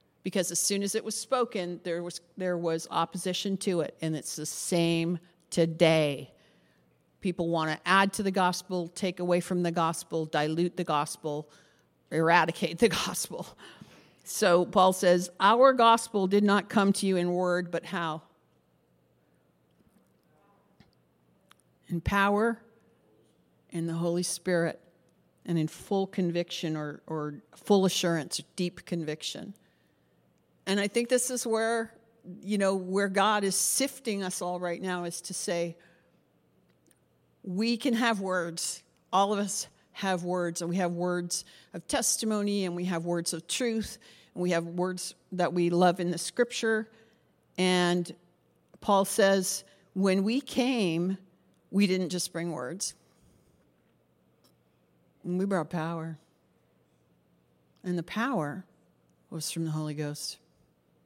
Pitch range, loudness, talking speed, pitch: 165-195 Hz, -29 LUFS, 135 wpm, 175 Hz